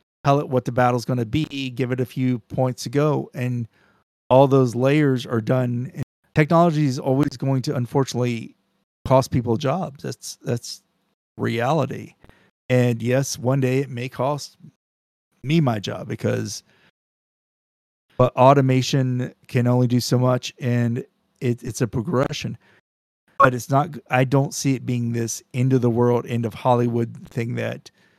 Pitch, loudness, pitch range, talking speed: 125 Hz, -21 LUFS, 120-135 Hz, 155 wpm